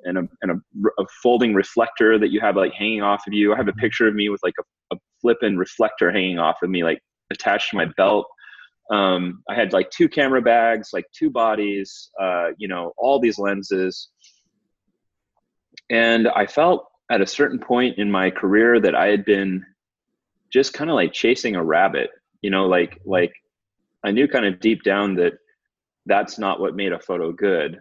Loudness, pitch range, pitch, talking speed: -20 LUFS, 95-120 Hz, 105 Hz, 195 wpm